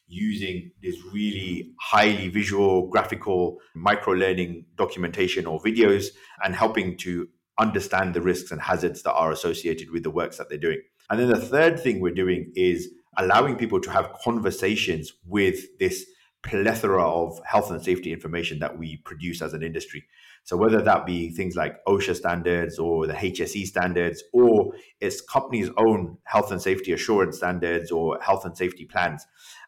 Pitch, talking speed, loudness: 95 Hz, 165 wpm, -24 LUFS